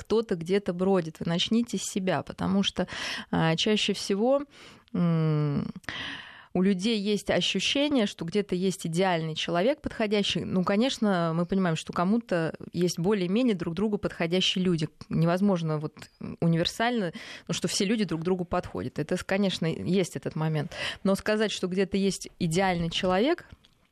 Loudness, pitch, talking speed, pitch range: -27 LUFS, 185 Hz, 145 wpm, 170-210 Hz